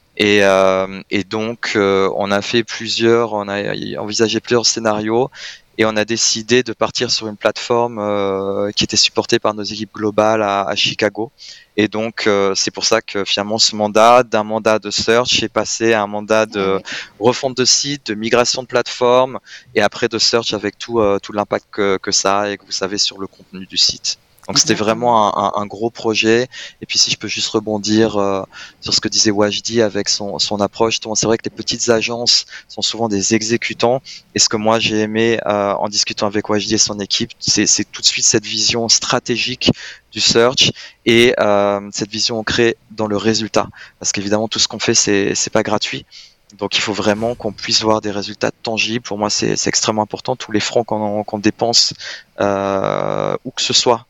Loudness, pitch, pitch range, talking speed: -16 LUFS, 110 Hz, 100-115 Hz, 205 wpm